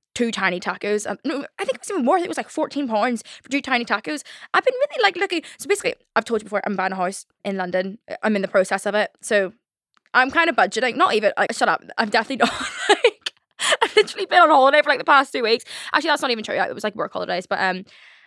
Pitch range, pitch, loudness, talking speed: 205-315 Hz, 250 Hz, -20 LUFS, 275 wpm